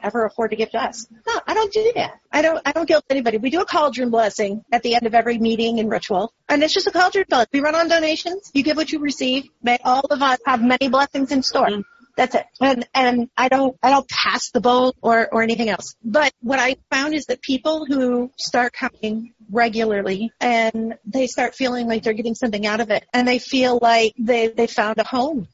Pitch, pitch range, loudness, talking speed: 250 Hz, 230-280 Hz, -19 LUFS, 235 wpm